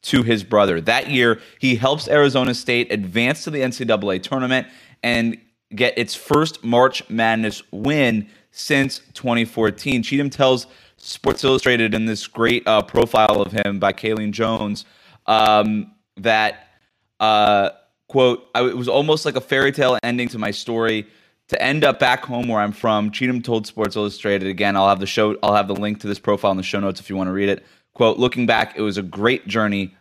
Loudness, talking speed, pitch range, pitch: -19 LUFS, 190 wpm, 105-125 Hz, 115 Hz